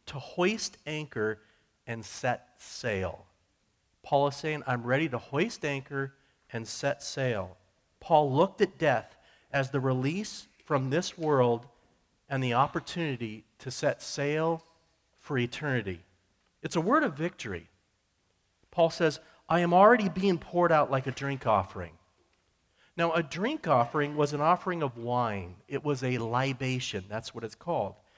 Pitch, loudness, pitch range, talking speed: 135 Hz, -30 LUFS, 110-155 Hz, 145 wpm